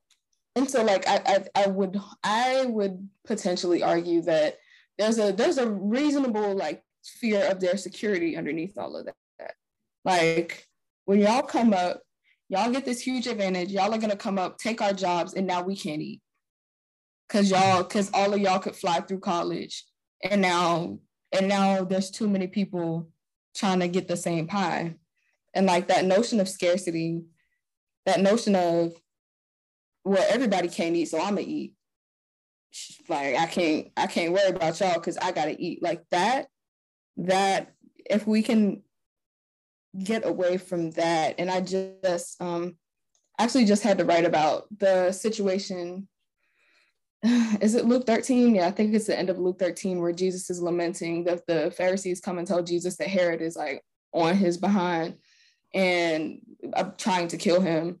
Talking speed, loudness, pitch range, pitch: 165 wpm, -26 LUFS, 175-205 Hz, 190 Hz